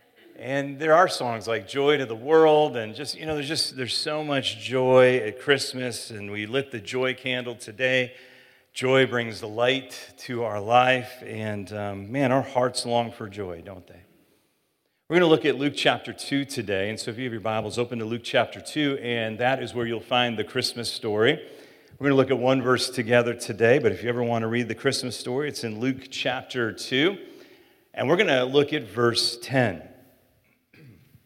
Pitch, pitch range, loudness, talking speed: 125 Hz, 115-135 Hz, -24 LUFS, 205 wpm